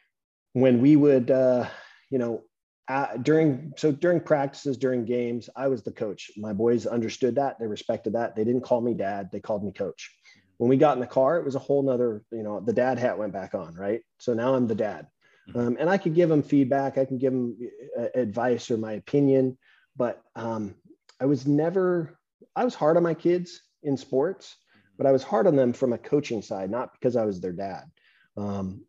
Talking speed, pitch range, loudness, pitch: 215 wpm, 120-145 Hz, -25 LUFS, 130 Hz